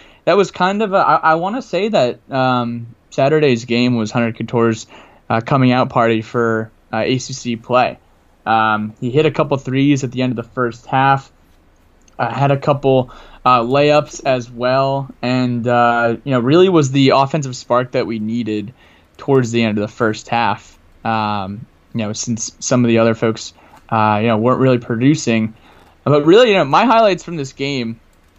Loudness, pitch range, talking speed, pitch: -16 LUFS, 110-135 Hz, 185 wpm, 120 Hz